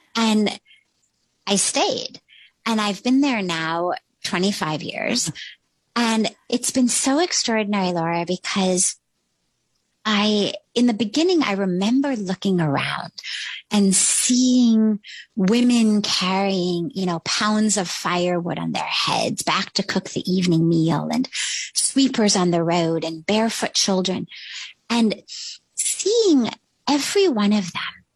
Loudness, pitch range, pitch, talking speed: -20 LUFS, 180-235 Hz, 205 Hz, 120 wpm